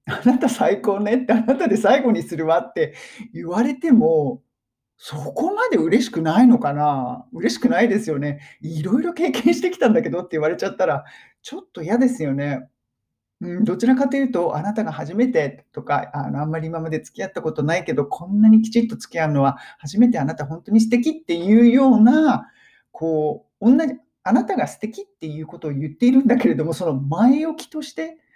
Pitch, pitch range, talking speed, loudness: 210 Hz, 155-250 Hz, 395 characters per minute, -19 LUFS